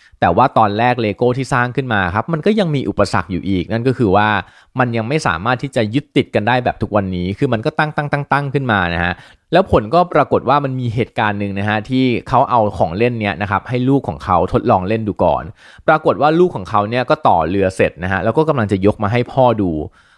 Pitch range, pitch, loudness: 100-135 Hz, 115 Hz, -16 LUFS